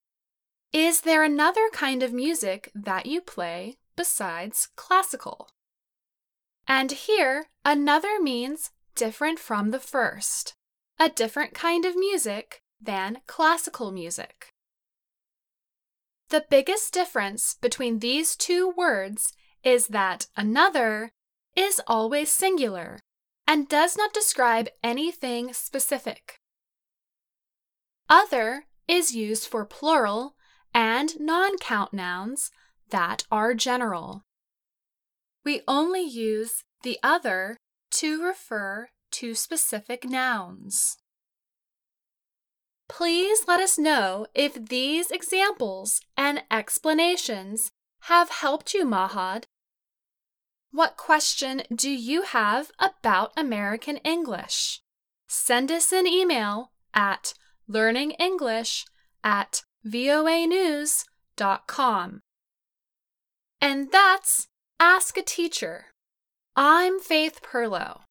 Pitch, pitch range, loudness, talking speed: 280 Hz, 230-335 Hz, -24 LUFS, 90 wpm